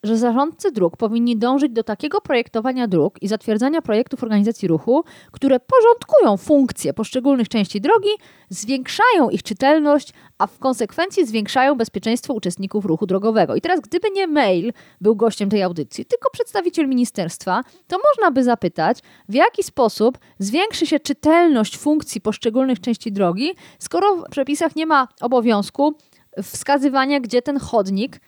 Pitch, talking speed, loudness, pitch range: 250 Hz, 140 wpm, -19 LUFS, 220-300 Hz